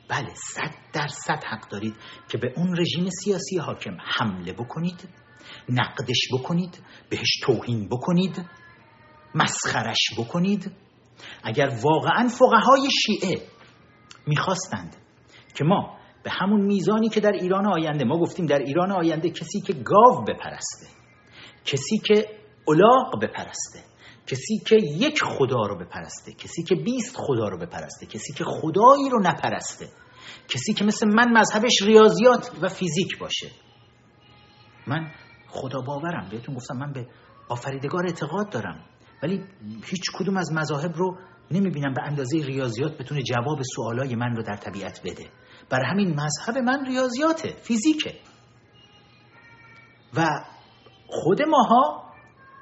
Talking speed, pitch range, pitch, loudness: 130 wpm, 125-195 Hz, 160 Hz, -23 LUFS